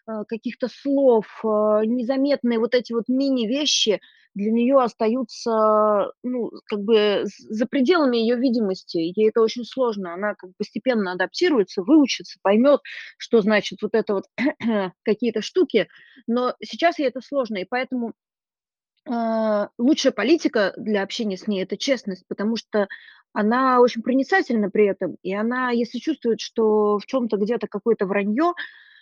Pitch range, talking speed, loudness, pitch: 210-260 Hz, 140 wpm, -22 LUFS, 230 Hz